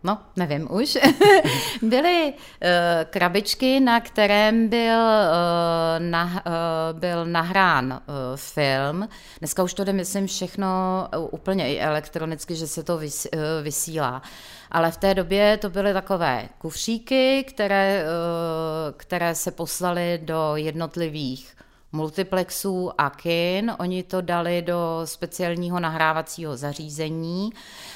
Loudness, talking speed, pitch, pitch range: -23 LUFS, 120 wpm, 175 Hz, 160-200 Hz